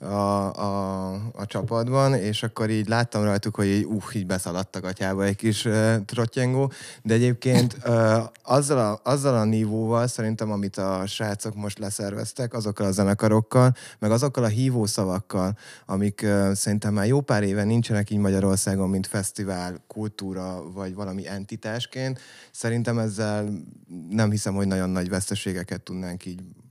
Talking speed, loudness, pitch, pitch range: 150 wpm, -25 LUFS, 105 Hz, 100-115 Hz